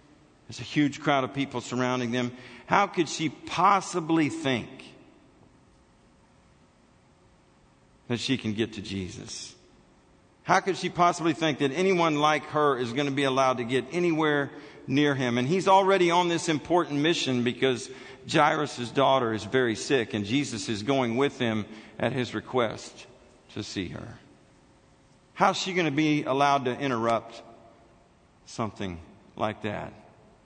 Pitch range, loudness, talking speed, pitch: 115-155 Hz, -26 LUFS, 145 wpm, 135 Hz